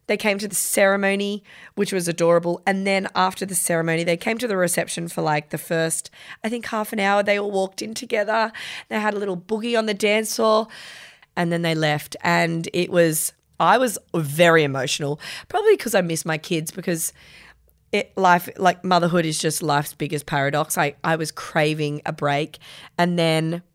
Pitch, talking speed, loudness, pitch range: 175 Hz, 190 wpm, -21 LUFS, 160-200 Hz